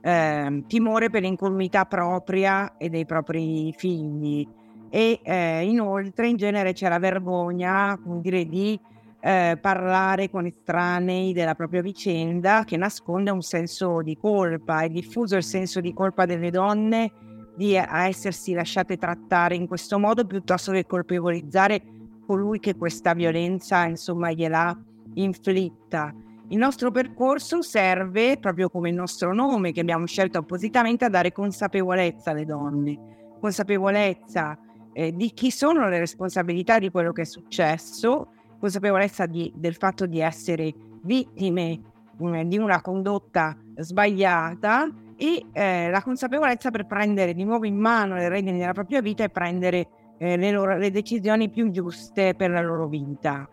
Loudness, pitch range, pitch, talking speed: -24 LUFS, 170-200 Hz, 185 Hz, 145 wpm